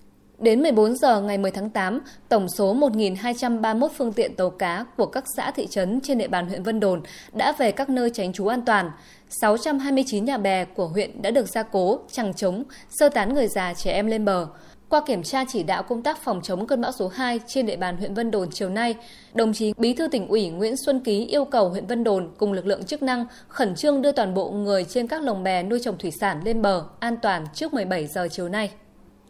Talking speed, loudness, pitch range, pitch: 235 wpm, -24 LUFS, 190-250 Hz, 220 Hz